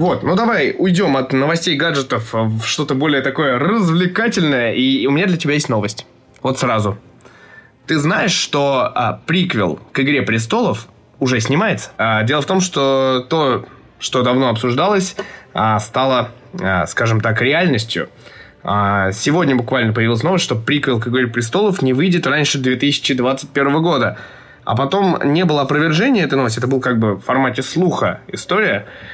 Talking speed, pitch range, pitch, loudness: 155 wpm, 125-165 Hz, 135 Hz, -16 LUFS